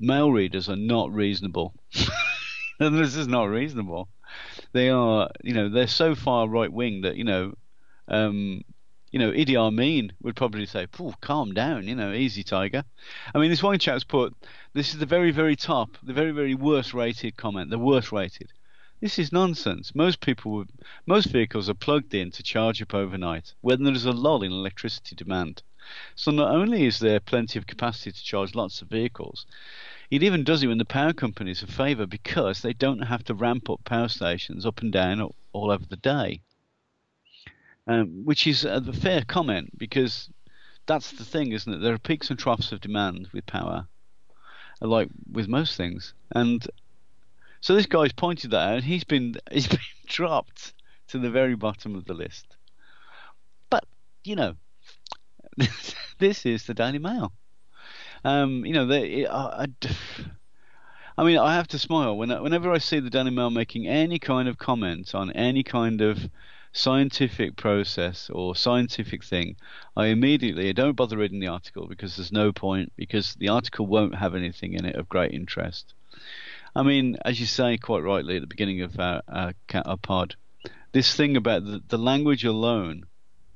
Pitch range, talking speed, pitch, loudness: 100-135 Hz, 175 wpm, 115 Hz, -25 LUFS